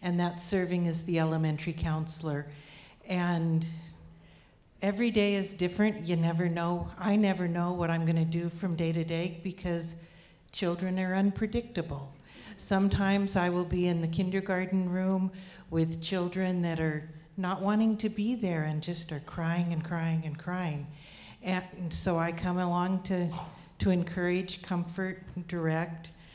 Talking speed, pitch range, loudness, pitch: 150 wpm, 165-185 Hz, -31 LUFS, 175 Hz